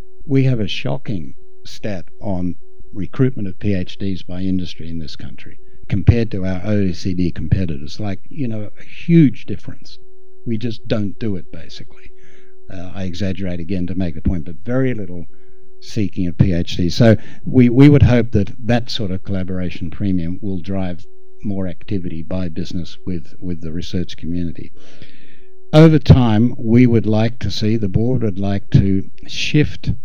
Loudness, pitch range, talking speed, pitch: -18 LUFS, 90-125 Hz, 160 wpm, 100 Hz